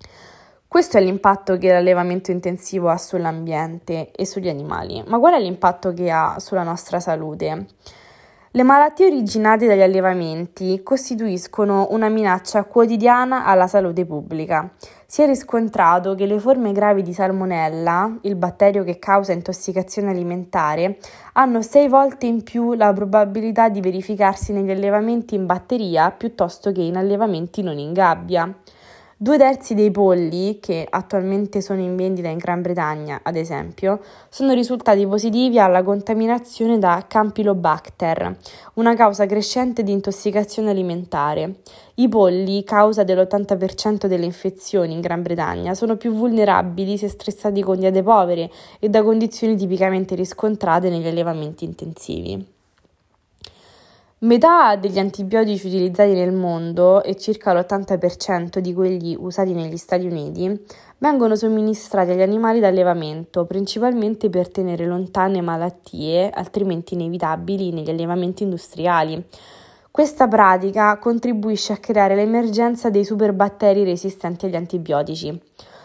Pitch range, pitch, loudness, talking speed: 175-215 Hz, 195 Hz, -18 LUFS, 125 wpm